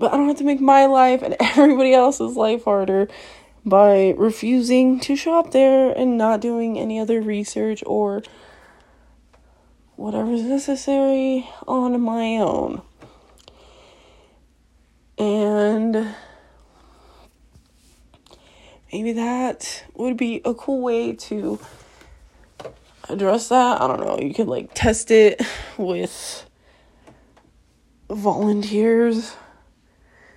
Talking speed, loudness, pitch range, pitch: 105 wpm, -19 LUFS, 210-260 Hz, 230 Hz